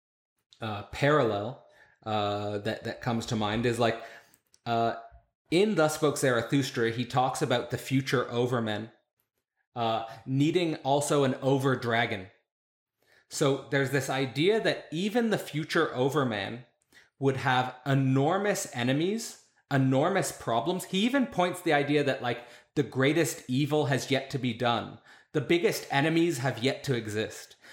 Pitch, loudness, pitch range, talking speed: 130 Hz, -28 LUFS, 115-150 Hz, 140 wpm